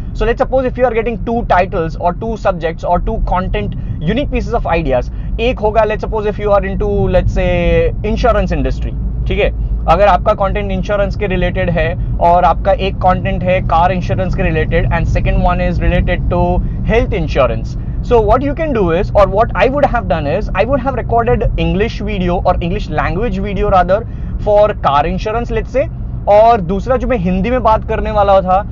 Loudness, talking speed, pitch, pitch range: -14 LUFS, 205 wpm, 195 Hz, 175-220 Hz